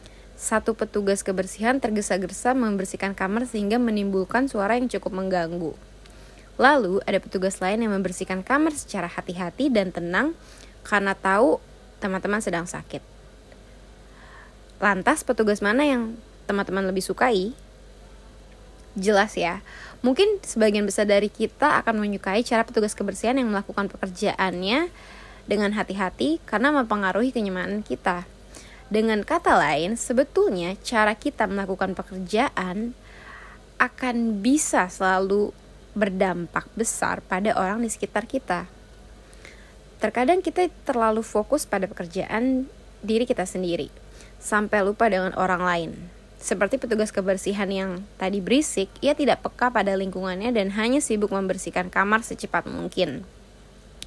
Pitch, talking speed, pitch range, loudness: 205 Hz, 120 wpm, 190-235 Hz, -24 LUFS